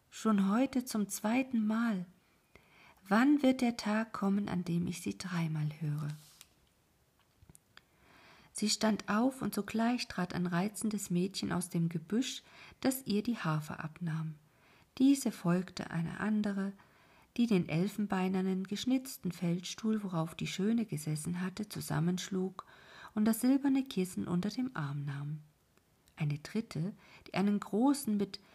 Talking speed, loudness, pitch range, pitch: 130 wpm, -34 LUFS, 170-220 Hz, 195 Hz